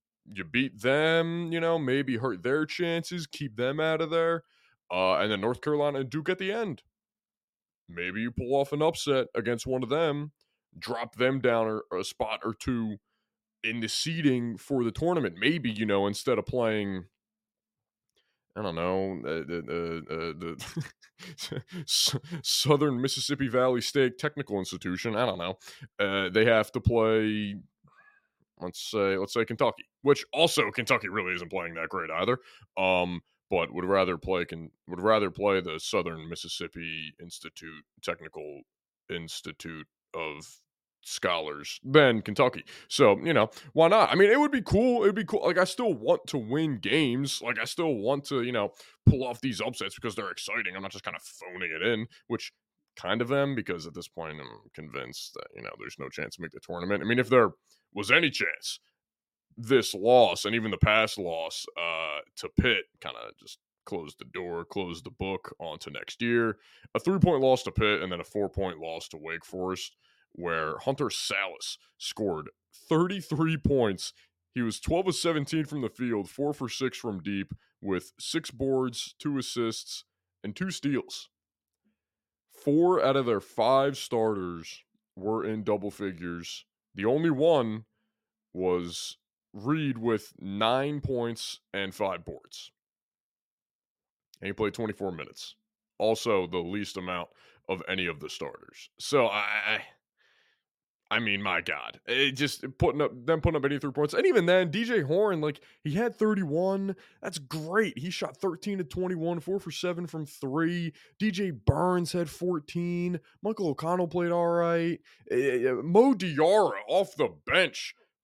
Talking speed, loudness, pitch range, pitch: 170 wpm, -28 LUFS, 100-165 Hz, 130 Hz